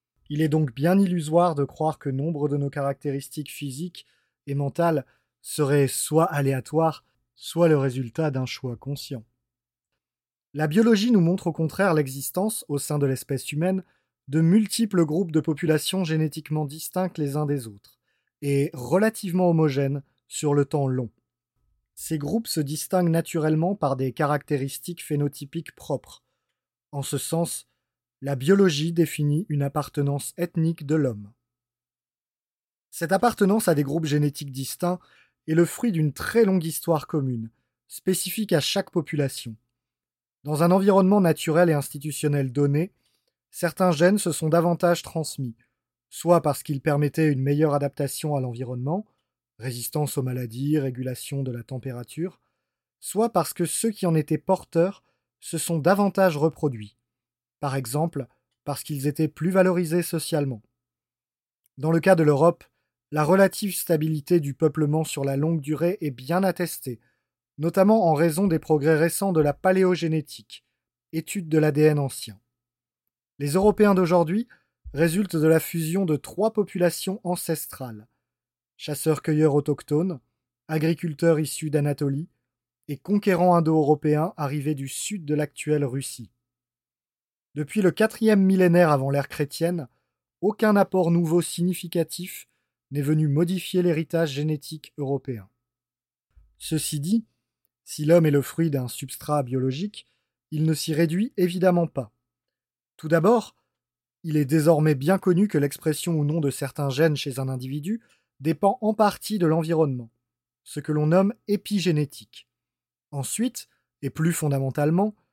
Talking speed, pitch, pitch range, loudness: 135 wpm, 155 Hz, 140-175 Hz, -24 LUFS